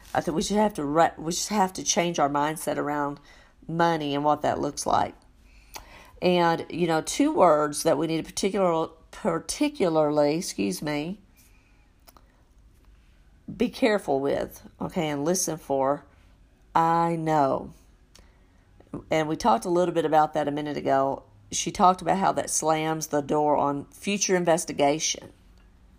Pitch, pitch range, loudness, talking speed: 155 Hz, 145-170 Hz, -25 LUFS, 150 wpm